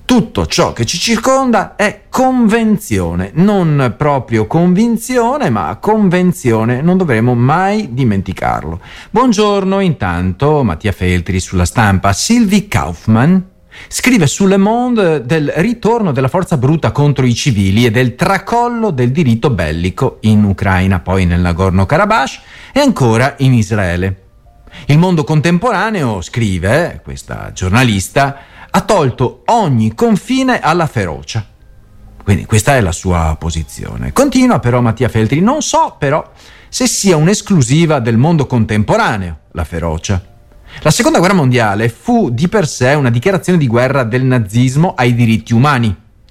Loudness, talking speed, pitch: -12 LUFS, 130 wpm, 125 Hz